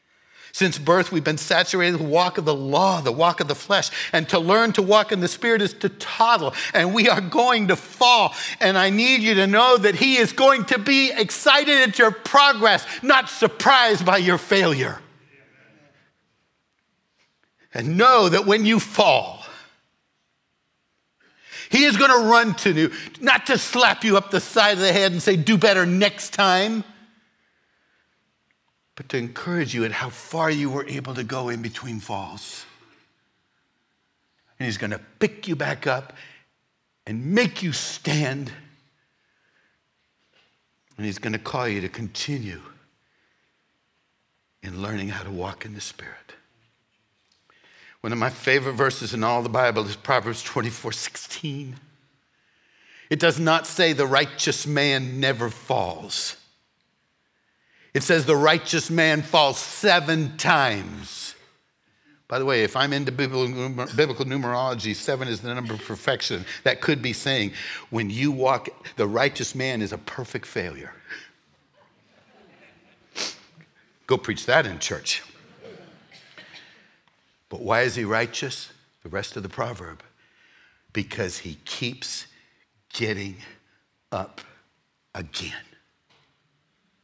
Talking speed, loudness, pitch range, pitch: 140 wpm, -20 LUFS, 120-195 Hz, 145 Hz